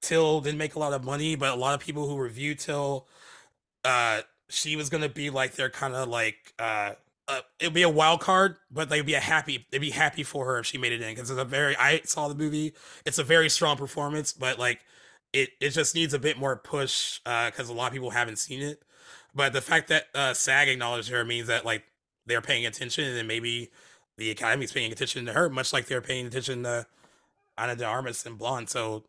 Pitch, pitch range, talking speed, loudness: 135 Hz, 125-150 Hz, 235 wpm, -27 LUFS